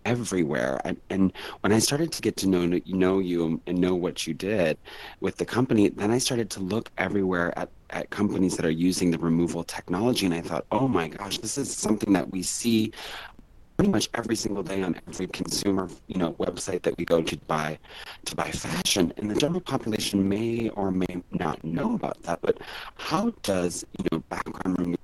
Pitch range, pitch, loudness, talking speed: 90-110 Hz, 95 Hz, -27 LUFS, 200 wpm